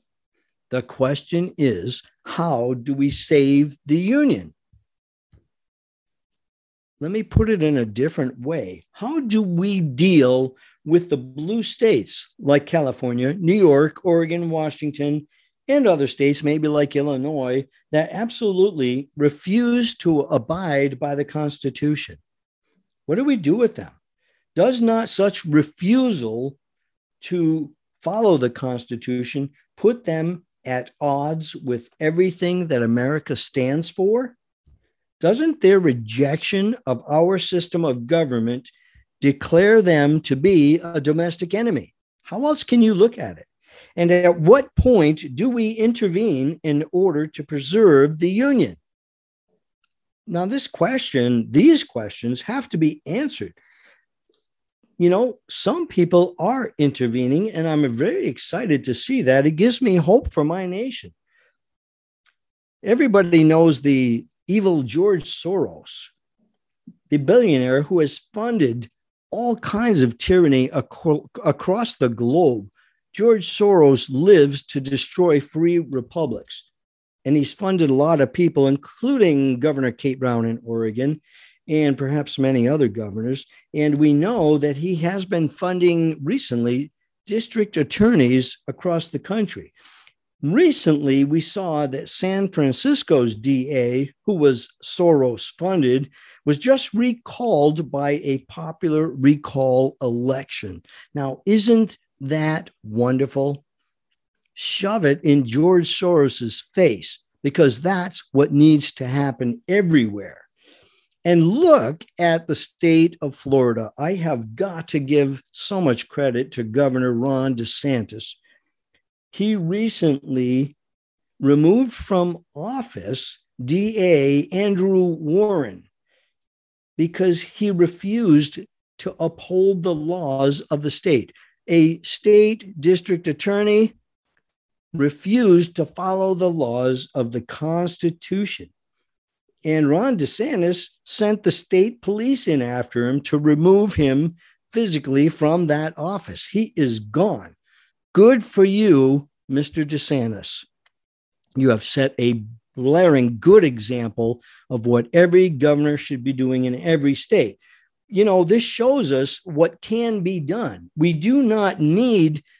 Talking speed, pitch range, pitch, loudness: 120 wpm, 135-190 Hz, 155 Hz, -19 LUFS